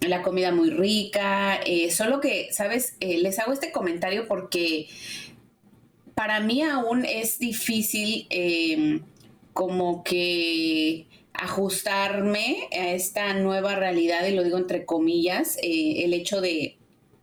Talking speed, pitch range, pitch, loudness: 125 wpm, 175-220 Hz, 195 Hz, -25 LUFS